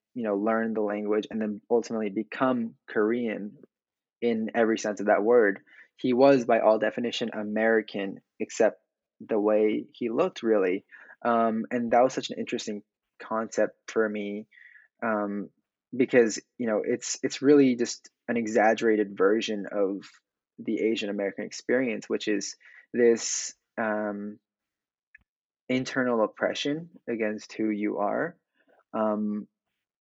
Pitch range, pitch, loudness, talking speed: 105-115 Hz, 110 Hz, -27 LUFS, 130 wpm